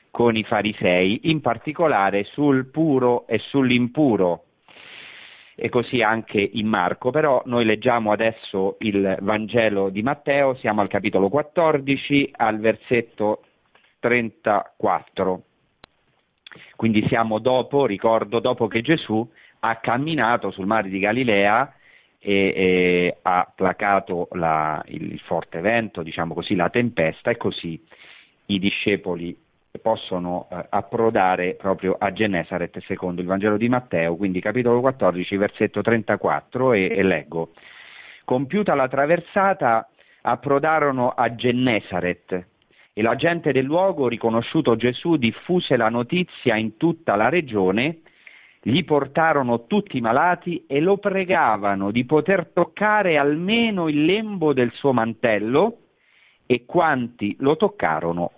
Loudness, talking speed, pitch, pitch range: -21 LUFS, 120 wpm, 115 Hz, 100-140 Hz